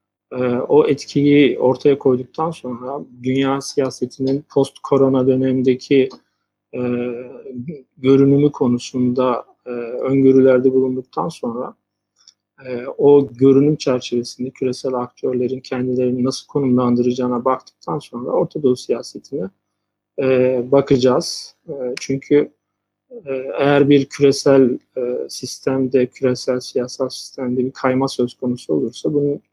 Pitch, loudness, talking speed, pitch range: 130 Hz, -18 LUFS, 100 wpm, 125-135 Hz